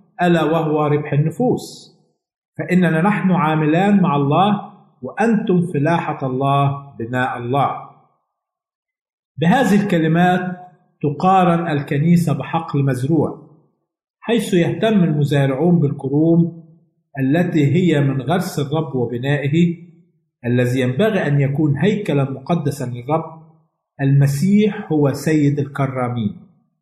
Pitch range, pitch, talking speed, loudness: 145-180 Hz, 160 Hz, 90 wpm, -17 LUFS